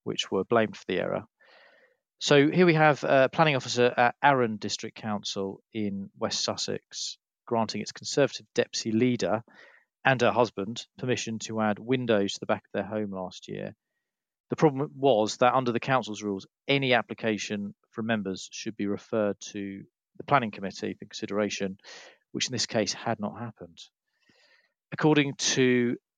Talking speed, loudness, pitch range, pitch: 160 wpm, -27 LUFS, 105-130 Hz, 115 Hz